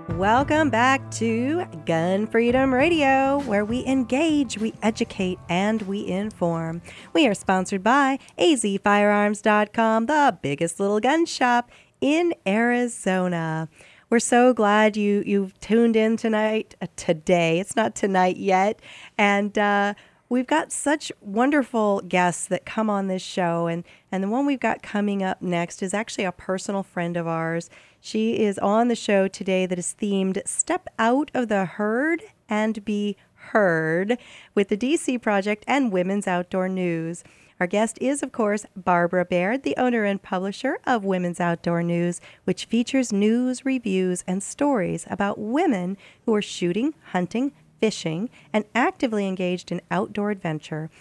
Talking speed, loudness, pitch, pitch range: 150 wpm, -23 LUFS, 205 Hz, 185-240 Hz